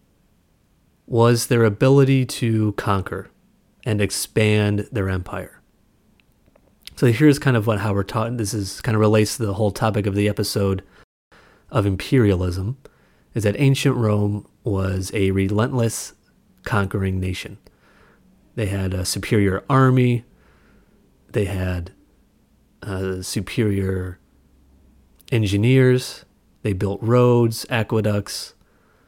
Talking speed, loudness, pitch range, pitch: 110 wpm, -20 LUFS, 95-115 Hz, 105 Hz